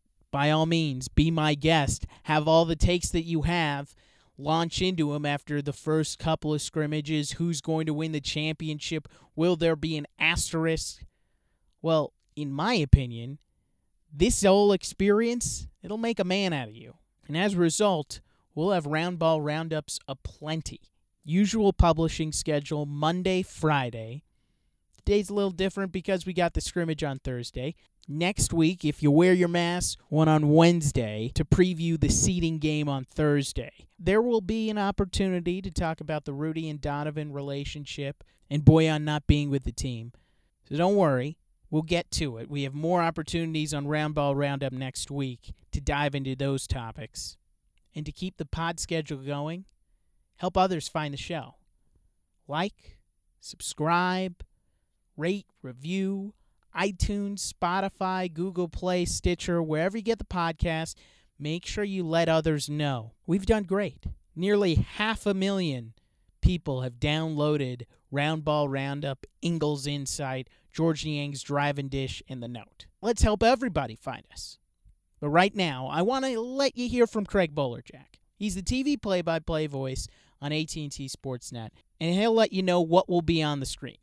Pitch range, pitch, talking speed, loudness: 140-180 Hz, 155 Hz, 160 wpm, -27 LUFS